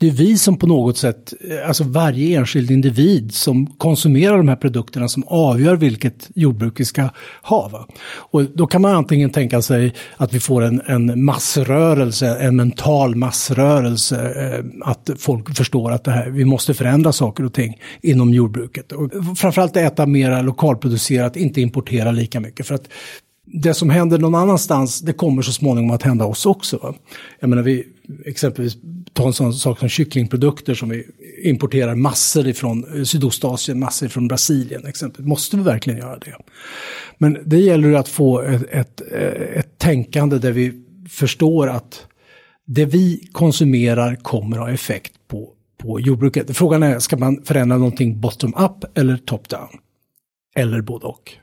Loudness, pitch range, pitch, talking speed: -17 LUFS, 125-150 Hz, 135 Hz, 160 wpm